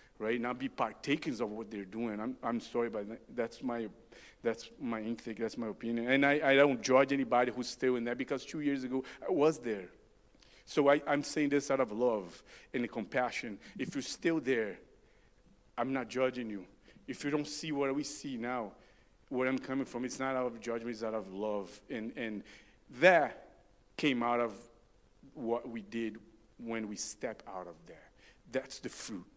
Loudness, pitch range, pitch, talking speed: -34 LUFS, 115-135 Hz, 125 Hz, 200 wpm